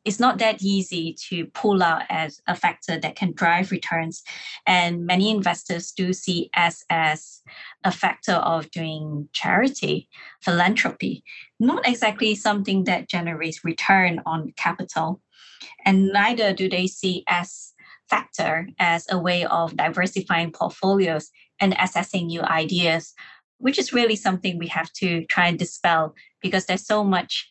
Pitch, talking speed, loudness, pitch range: 180 Hz, 145 wpm, -22 LUFS, 165-195 Hz